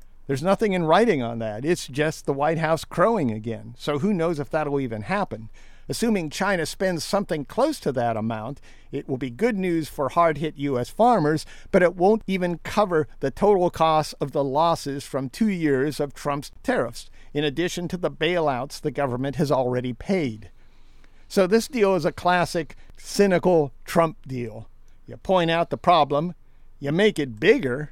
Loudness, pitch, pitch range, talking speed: -23 LUFS, 150 Hz, 130-175 Hz, 180 wpm